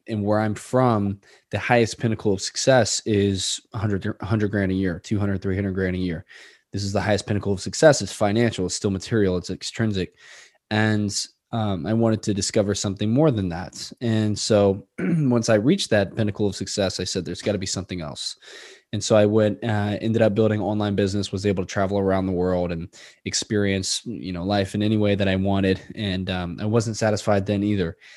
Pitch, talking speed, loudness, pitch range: 100 Hz, 205 wpm, -23 LUFS, 95-110 Hz